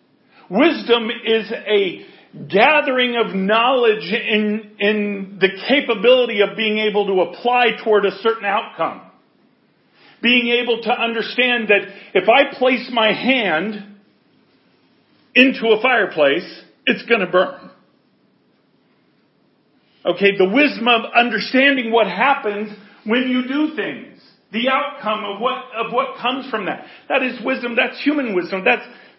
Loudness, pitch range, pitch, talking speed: -17 LUFS, 210-255 Hz, 235 Hz, 130 wpm